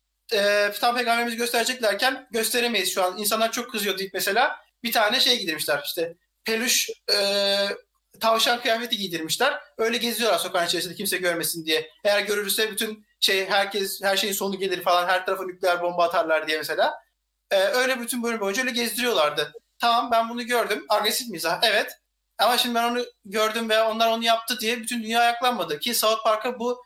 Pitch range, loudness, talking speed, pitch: 195-235 Hz, -23 LUFS, 175 wpm, 220 Hz